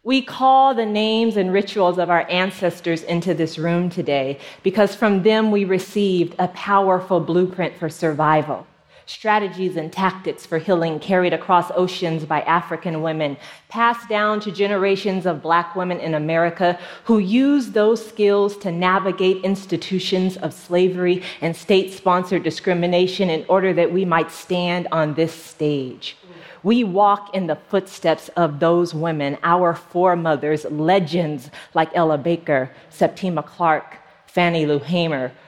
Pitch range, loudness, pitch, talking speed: 165-195 Hz, -19 LUFS, 180 Hz, 140 wpm